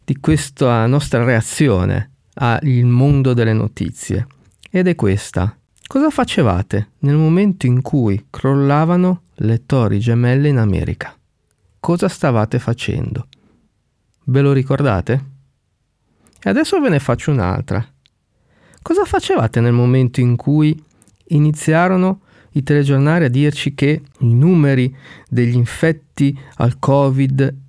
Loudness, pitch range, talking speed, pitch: -16 LUFS, 120-150 Hz, 115 wpm, 135 Hz